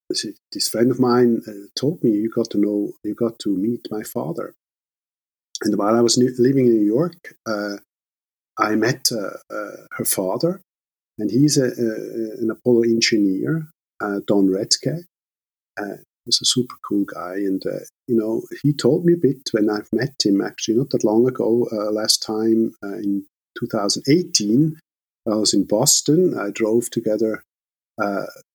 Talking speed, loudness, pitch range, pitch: 170 wpm, -20 LUFS, 105-125 Hz, 115 Hz